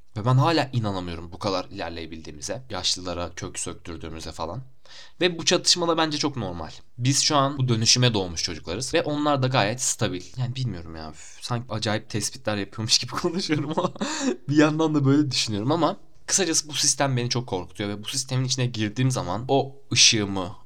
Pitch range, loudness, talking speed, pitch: 95-145 Hz, -23 LUFS, 175 wpm, 125 Hz